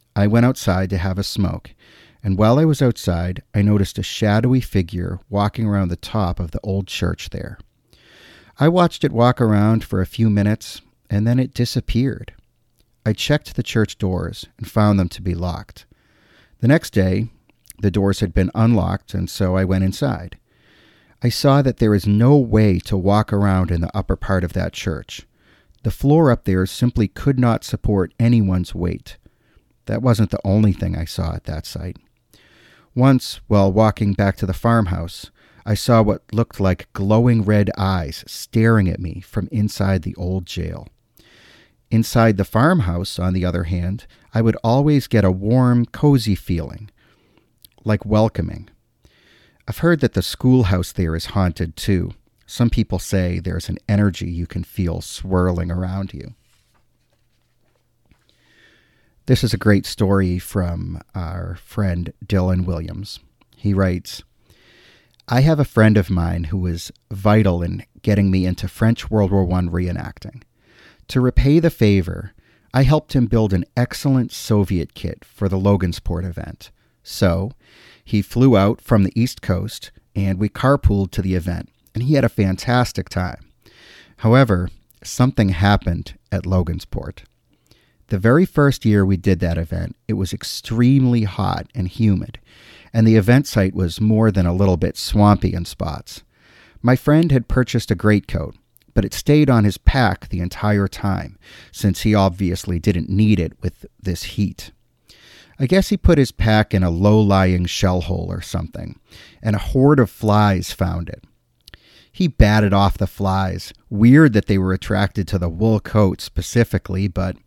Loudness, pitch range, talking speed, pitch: -18 LUFS, 95-115 Hz, 165 wpm, 100 Hz